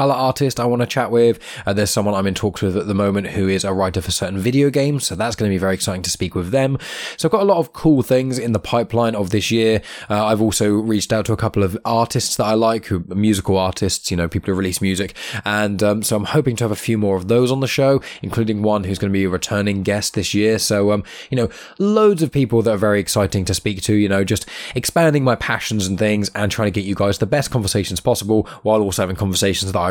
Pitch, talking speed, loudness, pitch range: 105 Hz, 275 wpm, -18 LUFS, 100-115 Hz